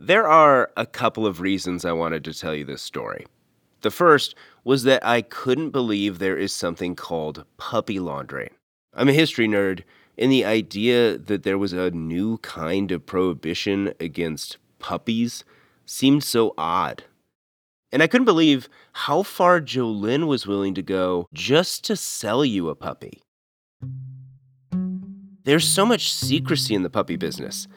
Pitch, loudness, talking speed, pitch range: 110 Hz, -22 LUFS, 155 wpm, 90-135 Hz